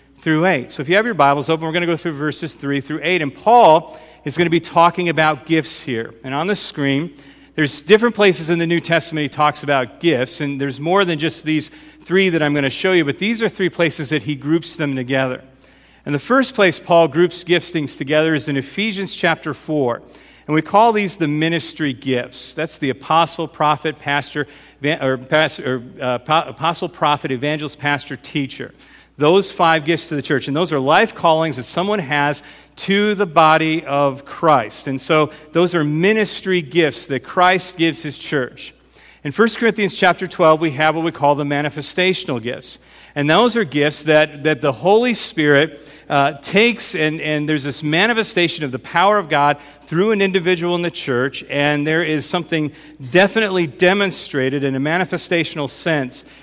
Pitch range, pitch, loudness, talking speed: 145-175 Hz, 155 Hz, -17 LUFS, 190 wpm